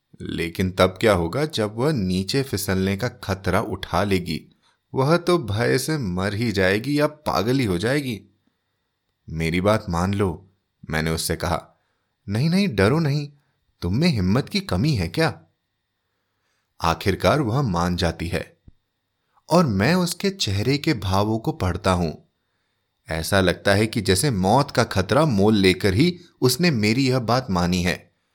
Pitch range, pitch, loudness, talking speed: 90-130 Hz, 100 Hz, -22 LUFS, 150 wpm